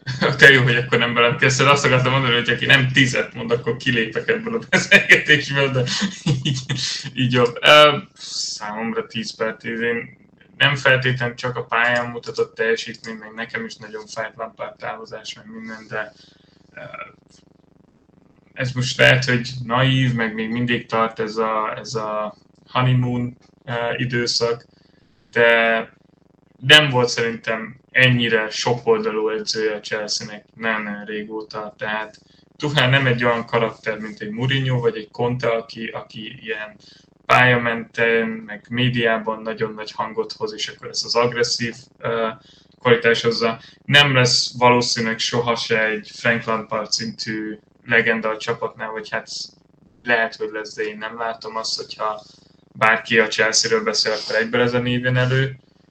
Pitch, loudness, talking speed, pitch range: 120 Hz, -18 LUFS, 145 wpm, 110-135 Hz